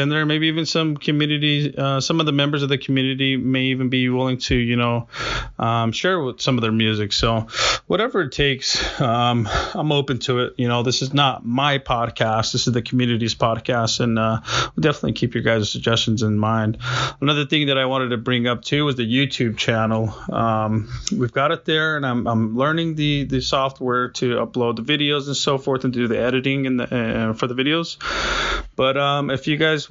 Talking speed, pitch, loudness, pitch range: 215 wpm, 130 Hz, -20 LUFS, 115-140 Hz